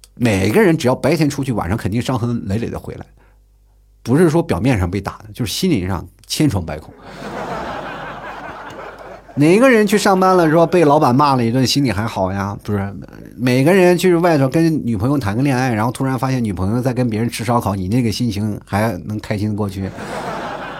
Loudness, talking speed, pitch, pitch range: -16 LUFS, 295 characters per minute, 120 Hz, 105-140 Hz